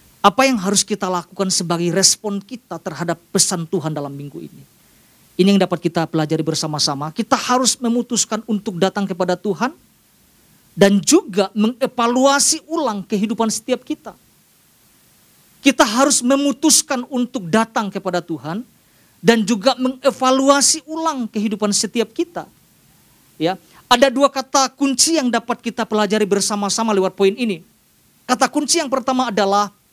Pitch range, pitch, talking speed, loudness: 190-260 Hz, 220 Hz, 130 wpm, -17 LUFS